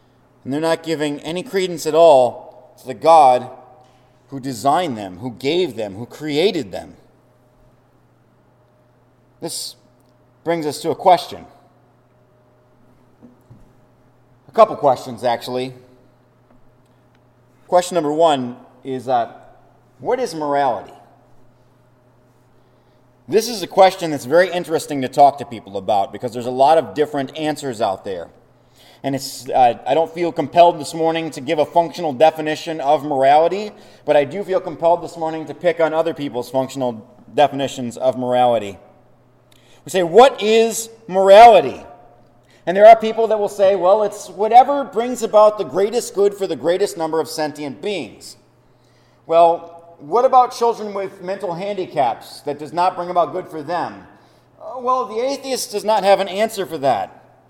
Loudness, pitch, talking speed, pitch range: -17 LUFS, 145 Hz, 150 wpm, 125-180 Hz